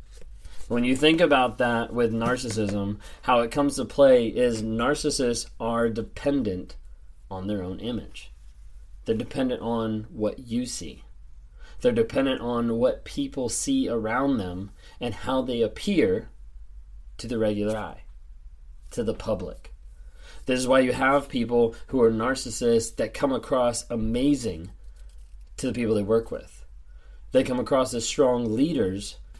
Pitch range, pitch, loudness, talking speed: 85-125 Hz, 115 Hz, -25 LUFS, 145 wpm